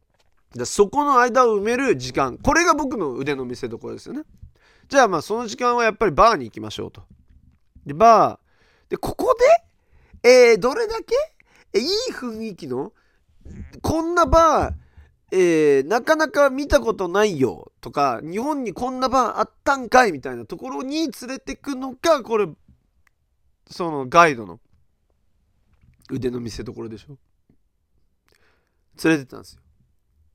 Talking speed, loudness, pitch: 290 characters per minute, -19 LUFS, 215 Hz